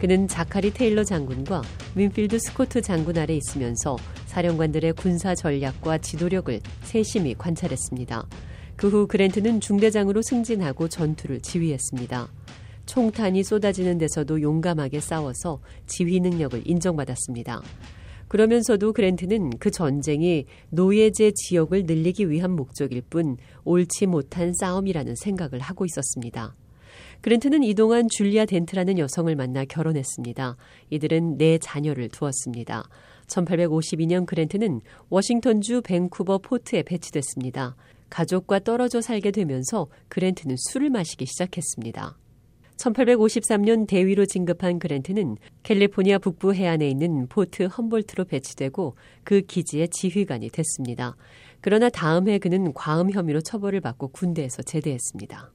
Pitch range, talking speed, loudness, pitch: 135-200 Hz, 330 characters per minute, -24 LUFS, 170 Hz